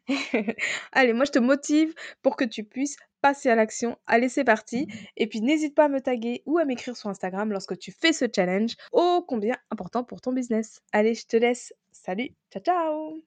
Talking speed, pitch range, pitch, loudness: 205 wpm, 220-280 Hz, 250 Hz, -25 LUFS